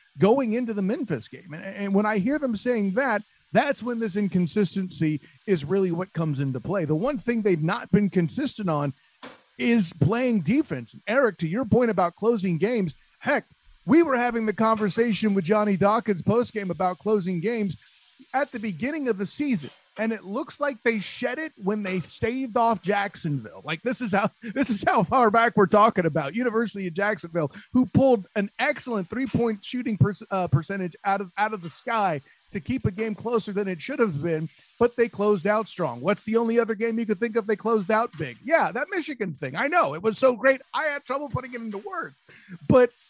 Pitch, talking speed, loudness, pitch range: 215 Hz, 205 wpm, -25 LUFS, 190-240 Hz